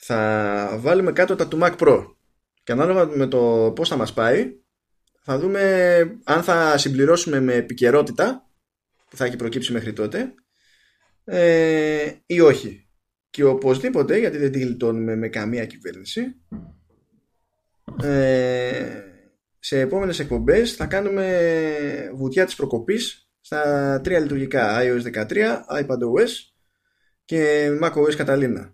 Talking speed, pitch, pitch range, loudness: 115 wpm, 145 Hz, 120-170 Hz, -20 LUFS